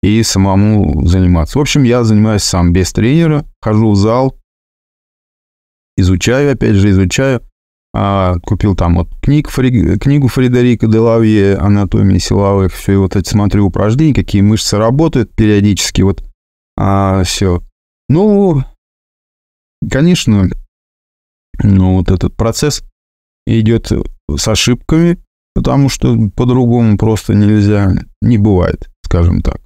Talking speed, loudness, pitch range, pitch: 120 wpm, -11 LUFS, 90-120 Hz, 105 Hz